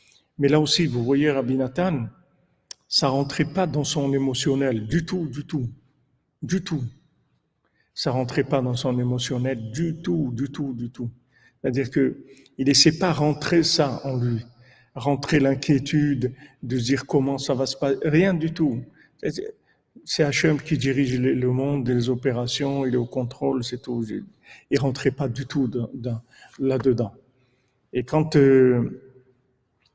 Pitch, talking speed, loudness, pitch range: 135 Hz, 160 wpm, -23 LUFS, 125-150 Hz